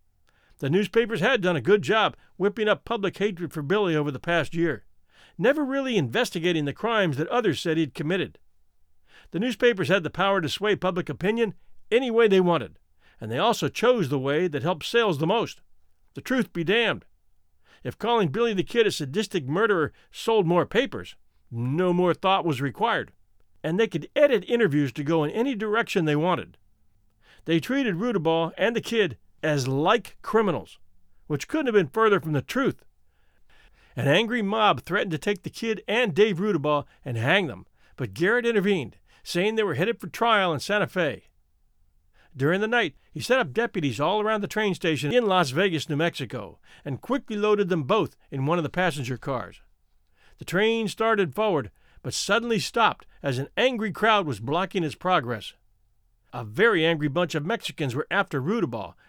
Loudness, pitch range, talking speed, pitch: -25 LUFS, 145-215 Hz, 180 wpm, 175 Hz